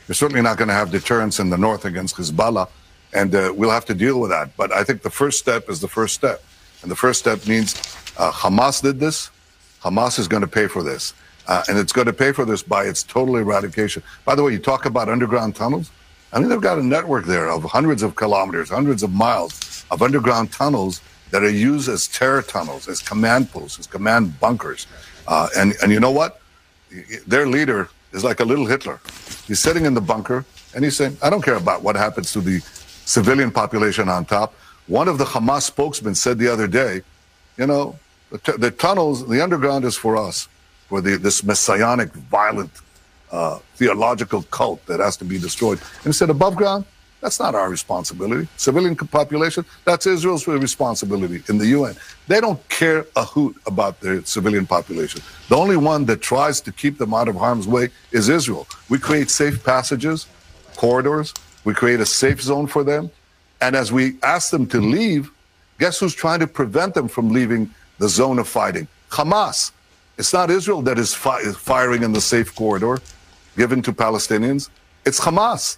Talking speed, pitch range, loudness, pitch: 195 wpm, 100-140 Hz, -19 LUFS, 115 Hz